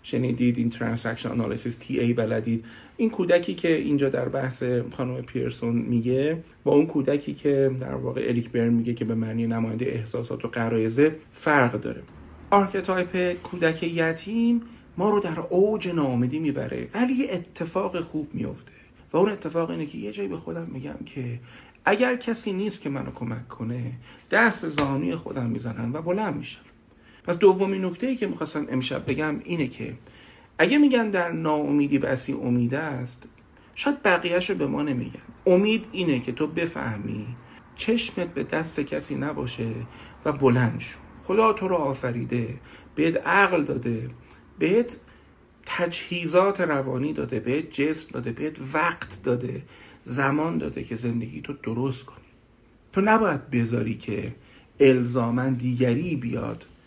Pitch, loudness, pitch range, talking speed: 135 Hz, -25 LUFS, 120-175 Hz, 150 wpm